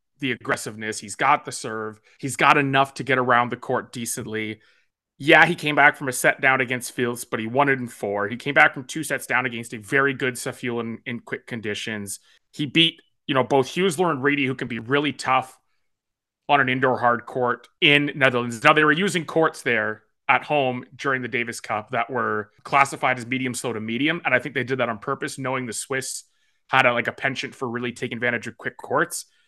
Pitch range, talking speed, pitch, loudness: 120-140 Hz, 225 wpm, 130 Hz, -22 LUFS